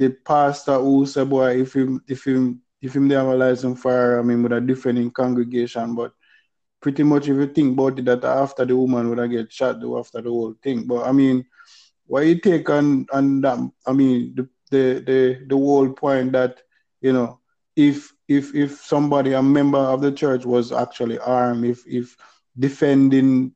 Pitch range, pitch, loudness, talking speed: 125-140 Hz, 130 Hz, -19 LUFS, 195 wpm